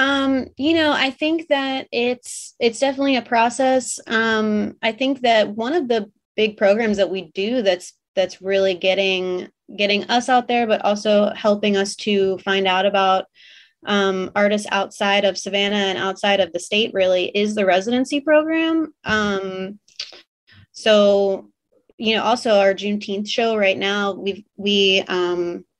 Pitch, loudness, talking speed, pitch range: 205 Hz, -19 LUFS, 155 wpm, 195-240 Hz